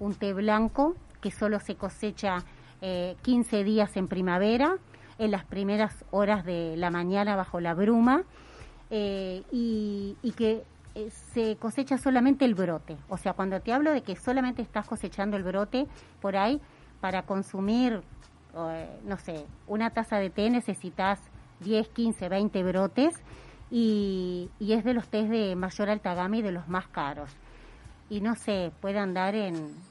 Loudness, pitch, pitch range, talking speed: -29 LUFS, 205 Hz, 185-225 Hz, 165 wpm